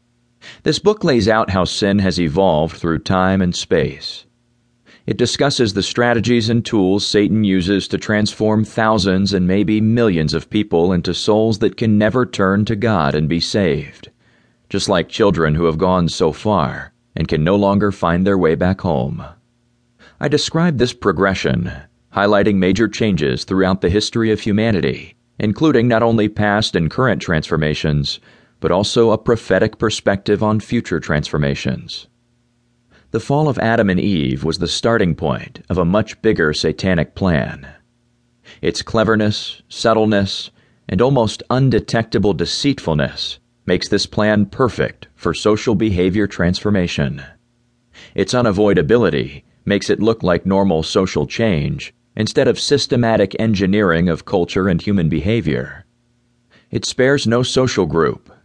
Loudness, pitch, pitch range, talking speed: -16 LUFS, 105 Hz, 95-120 Hz, 140 wpm